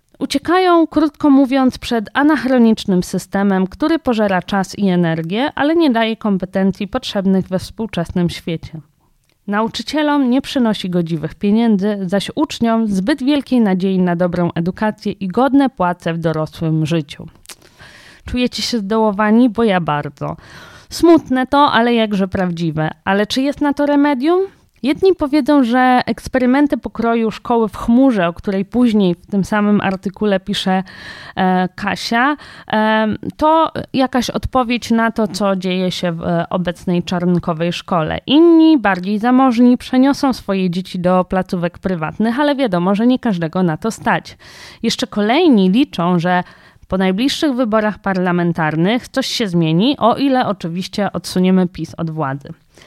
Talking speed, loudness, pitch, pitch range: 135 wpm, -16 LUFS, 210 Hz, 185-255 Hz